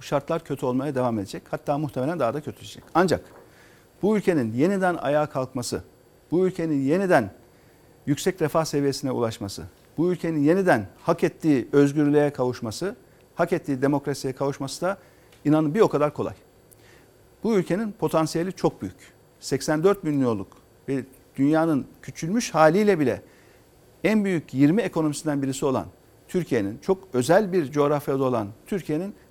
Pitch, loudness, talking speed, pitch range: 145 Hz, -24 LUFS, 135 wpm, 130-170 Hz